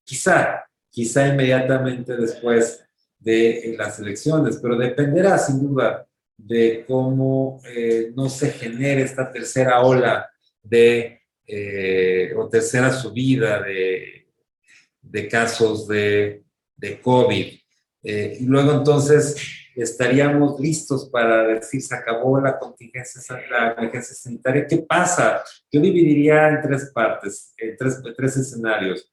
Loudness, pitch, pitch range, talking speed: -19 LUFS, 125 Hz, 115-135 Hz, 115 wpm